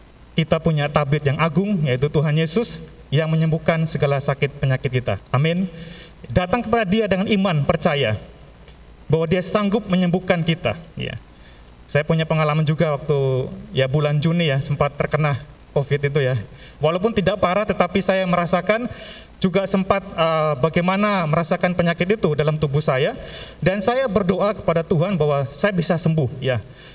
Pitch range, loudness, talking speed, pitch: 145-185 Hz, -20 LUFS, 150 wpm, 160 Hz